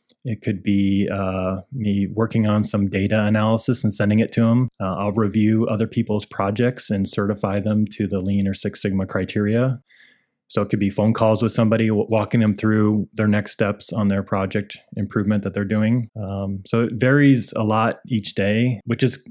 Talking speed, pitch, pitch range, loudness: 195 wpm, 105 Hz, 100-115 Hz, -20 LUFS